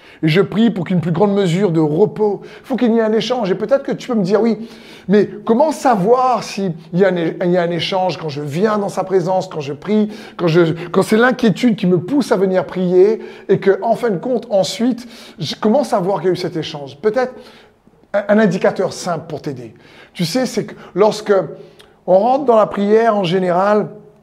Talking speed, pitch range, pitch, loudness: 215 wpm, 185-220 Hz, 200 Hz, -16 LUFS